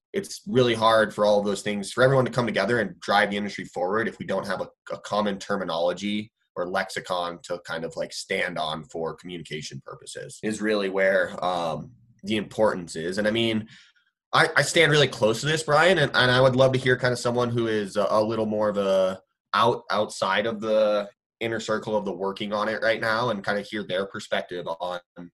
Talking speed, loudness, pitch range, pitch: 220 wpm, -24 LUFS, 100-120 Hz, 105 Hz